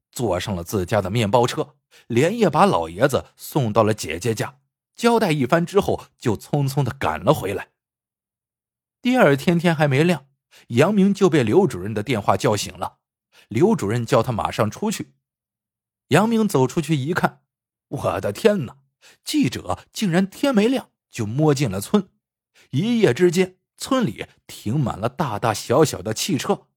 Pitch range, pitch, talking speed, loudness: 115-185 Hz, 145 Hz, 230 characters per minute, -21 LUFS